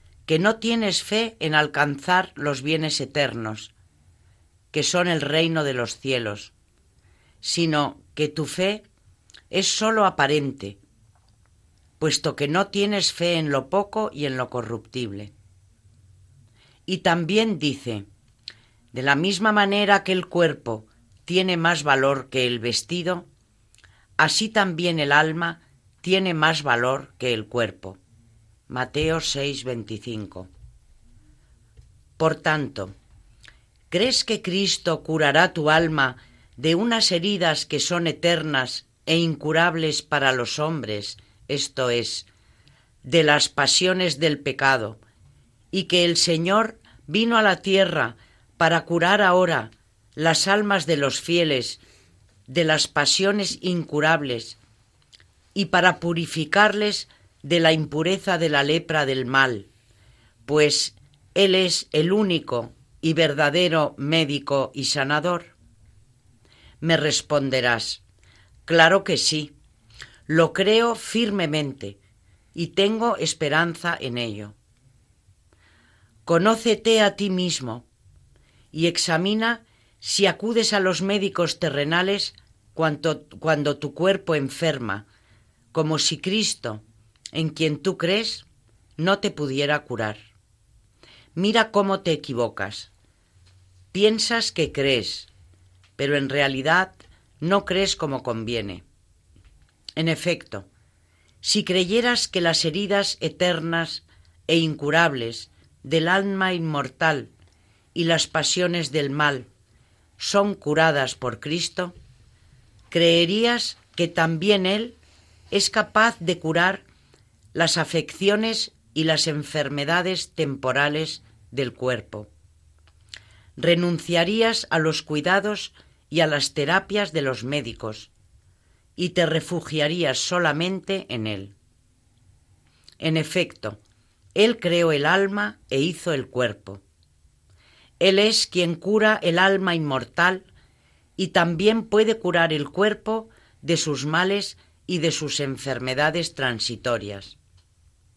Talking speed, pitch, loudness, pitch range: 110 wpm, 150 Hz, -22 LUFS, 110-175 Hz